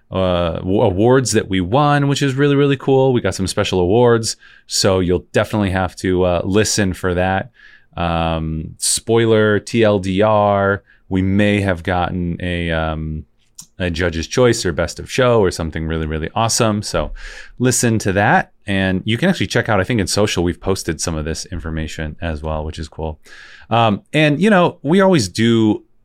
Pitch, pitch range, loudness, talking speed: 95 Hz, 85-115 Hz, -17 LUFS, 180 wpm